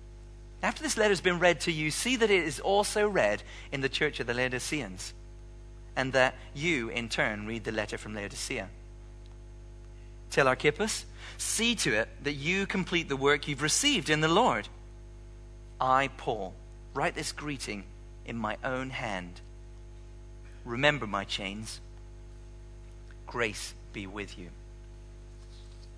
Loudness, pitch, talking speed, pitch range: -29 LUFS, 115 Hz, 140 wpm, 115-140 Hz